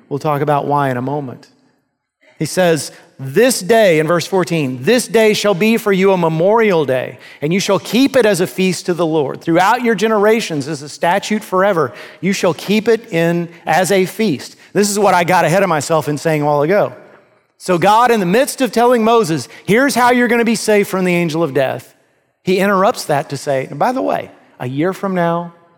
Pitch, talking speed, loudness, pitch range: 185 Hz, 220 wpm, -14 LUFS, 160-215 Hz